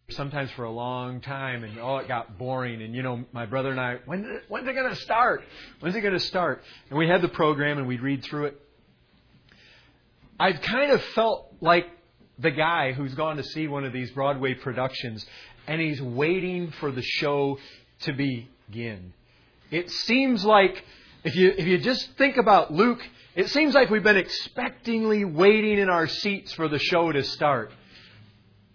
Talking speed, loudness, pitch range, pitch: 180 wpm, -25 LUFS, 125-180 Hz, 145 Hz